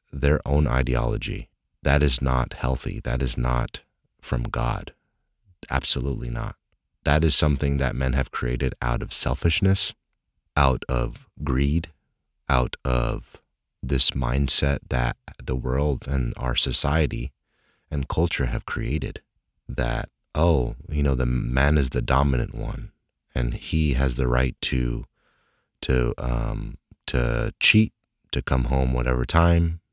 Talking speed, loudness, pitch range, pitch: 130 wpm, -24 LUFS, 65-75 Hz, 70 Hz